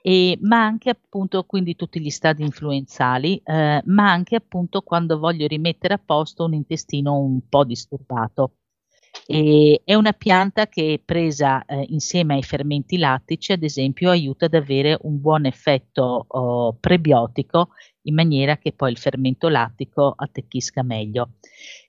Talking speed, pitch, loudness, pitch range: 145 wpm, 150 Hz, -20 LUFS, 135-170 Hz